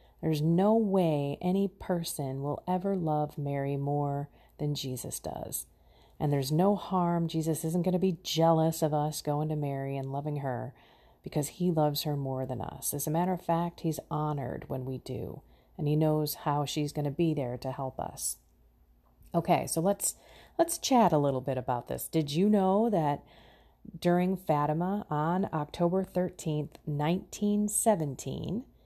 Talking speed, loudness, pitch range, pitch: 165 wpm, -30 LUFS, 140-180 Hz, 155 Hz